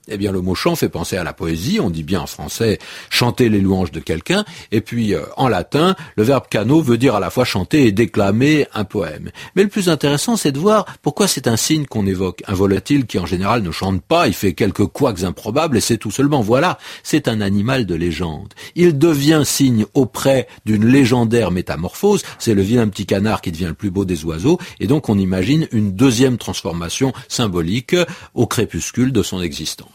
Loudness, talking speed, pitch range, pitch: -17 LUFS, 210 wpm, 95-140 Hz, 115 Hz